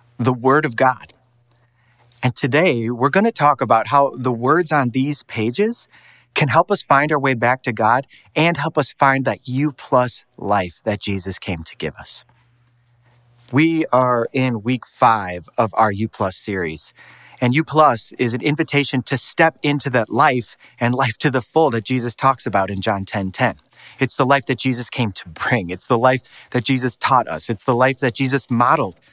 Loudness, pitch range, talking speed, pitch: -18 LUFS, 120-140 Hz, 200 wpm, 125 Hz